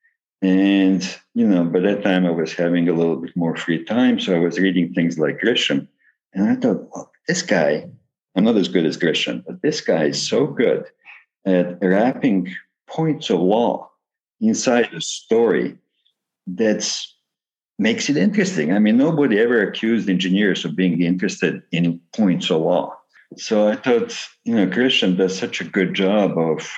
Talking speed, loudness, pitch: 175 wpm, -19 LUFS, 95 Hz